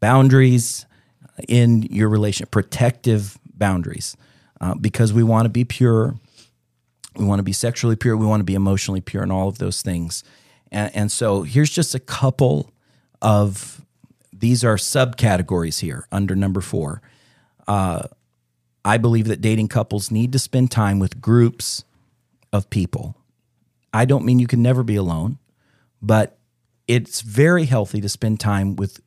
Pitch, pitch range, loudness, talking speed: 110 Hz, 100-125 Hz, -19 LUFS, 155 wpm